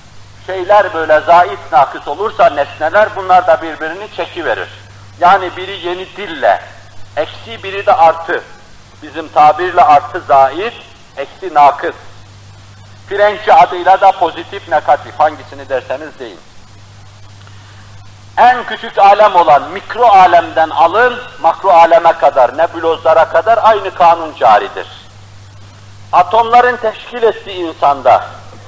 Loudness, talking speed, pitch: -11 LUFS, 110 wpm, 160 Hz